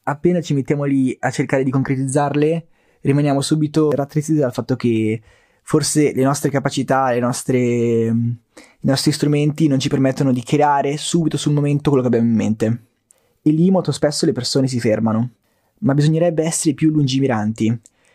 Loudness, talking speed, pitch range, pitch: -18 LUFS, 160 wpm, 120-150 Hz, 140 Hz